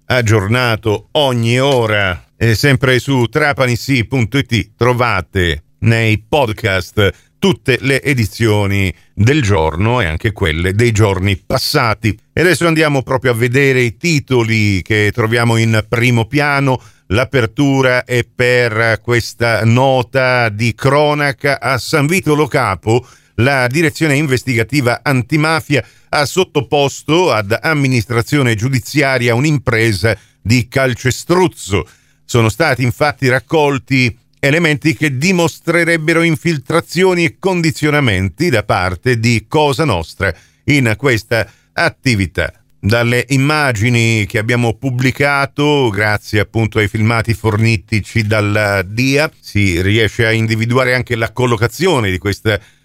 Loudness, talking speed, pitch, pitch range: -14 LUFS, 110 wpm, 125 Hz, 110-140 Hz